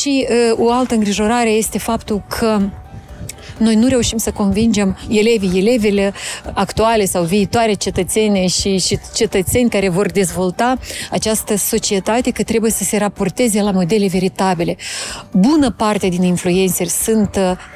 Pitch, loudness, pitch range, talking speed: 210 Hz, -15 LUFS, 195-225 Hz, 140 wpm